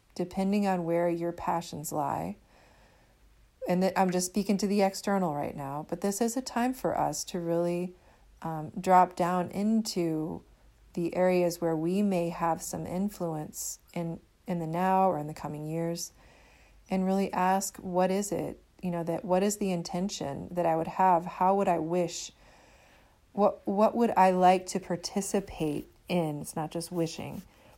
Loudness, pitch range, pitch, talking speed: -29 LUFS, 170-195 Hz, 180 Hz, 170 wpm